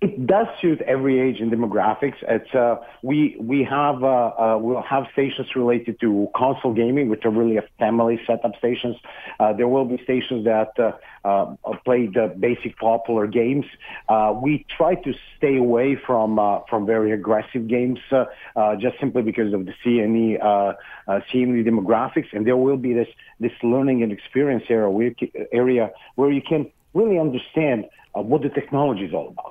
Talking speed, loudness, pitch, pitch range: 180 wpm, -21 LUFS, 120 Hz, 110-130 Hz